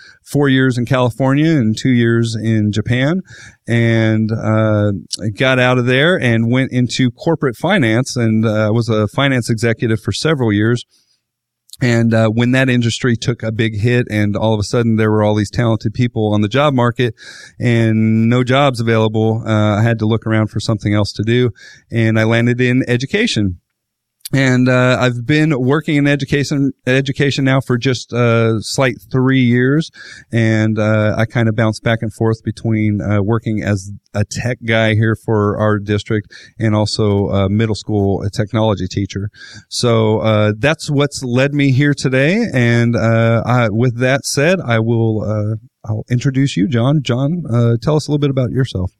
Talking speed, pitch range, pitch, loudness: 180 wpm, 110-130 Hz, 115 Hz, -15 LUFS